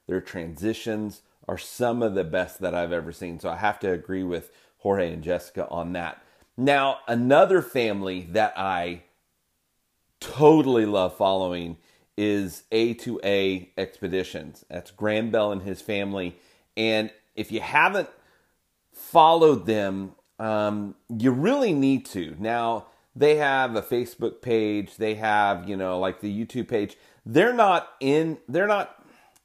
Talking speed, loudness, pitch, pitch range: 140 wpm, -24 LUFS, 105 Hz, 90-115 Hz